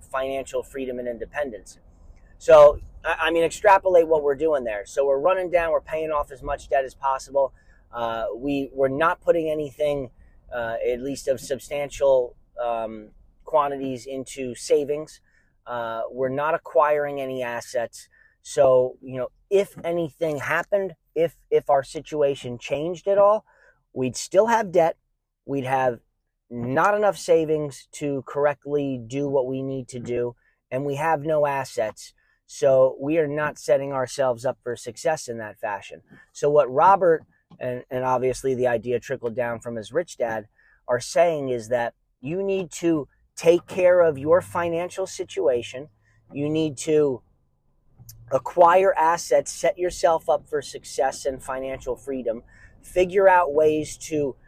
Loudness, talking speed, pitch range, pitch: -23 LUFS, 150 wpm, 125-160 Hz, 140 Hz